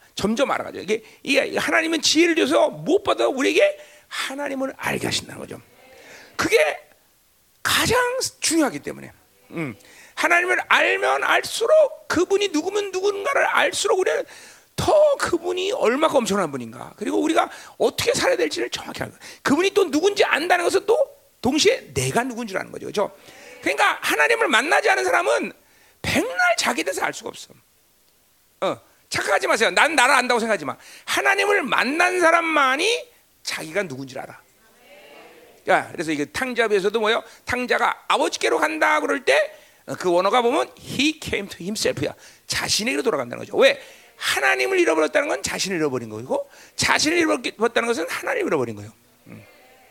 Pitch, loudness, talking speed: 300 Hz, -21 LUFS, 365 characters per minute